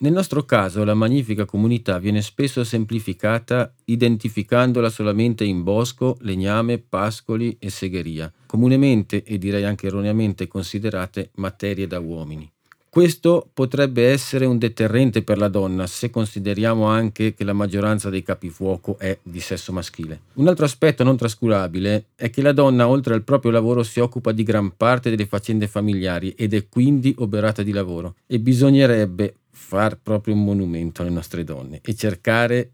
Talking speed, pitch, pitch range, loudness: 155 wpm, 110 Hz, 100-120 Hz, -20 LUFS